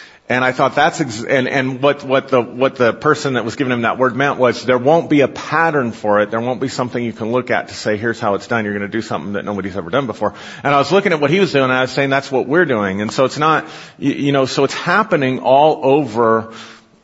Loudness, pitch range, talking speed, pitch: -16 LUFS, 115-140 Hz, 275 wpm, 130 Hz